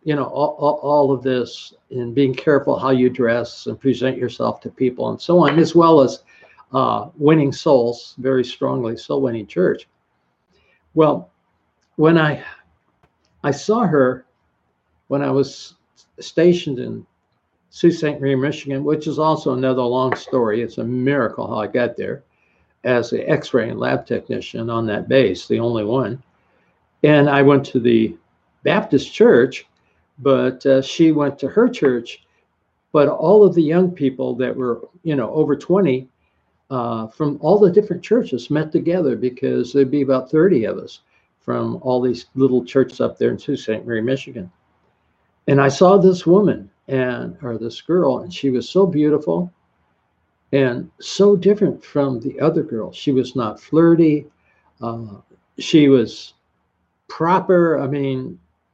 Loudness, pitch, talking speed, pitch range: -18 LUFS, 135 Hz, 155 wpm, 125-155 Hz